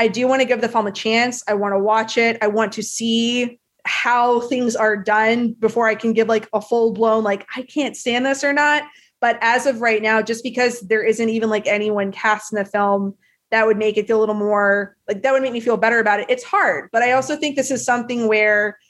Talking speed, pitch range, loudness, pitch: 255 wpm, 215-245 Hz, -18 LUFS, 225 Hz